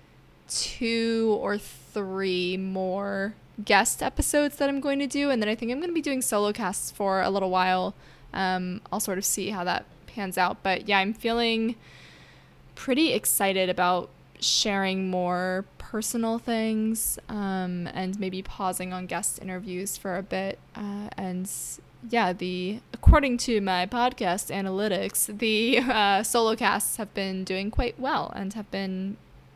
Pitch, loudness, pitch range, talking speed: 195 Hz, -26 LUFS, 185-225 Hz, 155 wpm